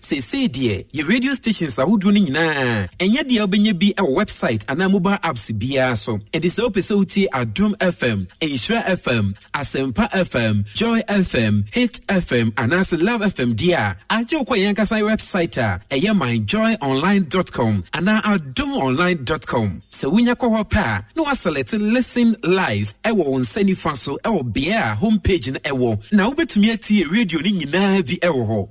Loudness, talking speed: -19 LUFS, 185 wpm